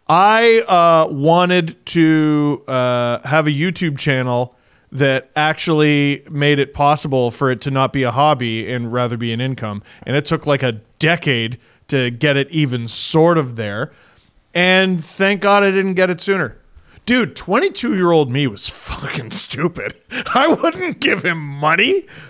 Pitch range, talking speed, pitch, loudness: 125-175 Hz, 160 wpm, 145 Hz, -16 LUFS